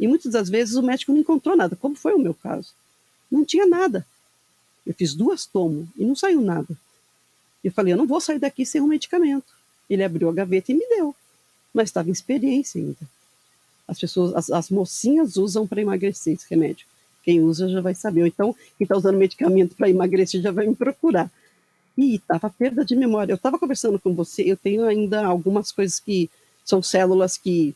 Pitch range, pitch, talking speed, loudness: 185-270 Hz, 205 Hz, 200 wpm, -21 LUFS